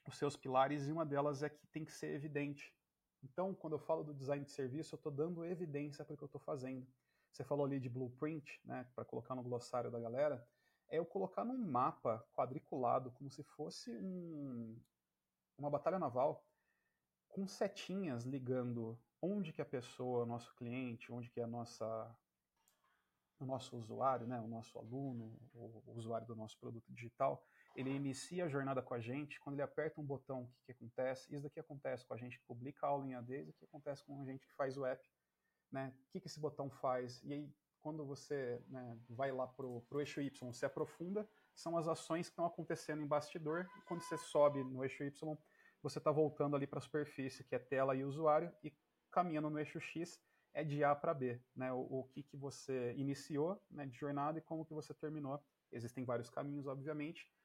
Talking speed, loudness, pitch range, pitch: 205 wpm, -44 LUFS, 130-155 Hz, 140 Hz